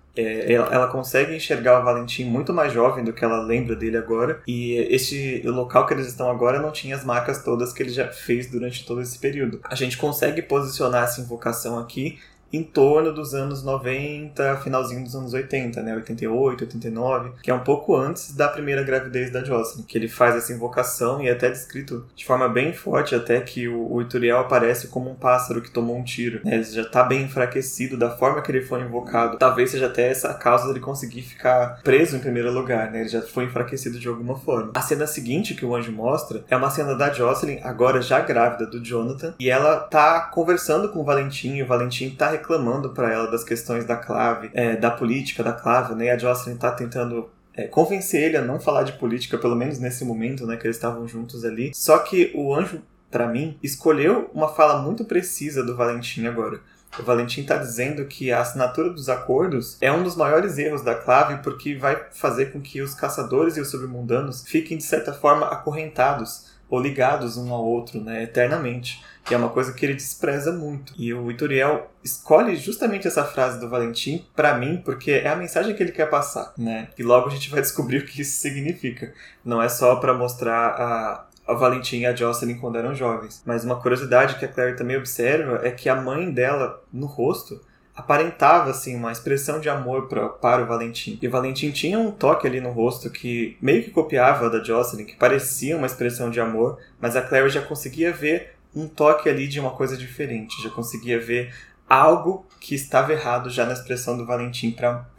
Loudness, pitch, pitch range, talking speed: -22 LUFS, 125 Hz, 120-140 Hz, 205 wpm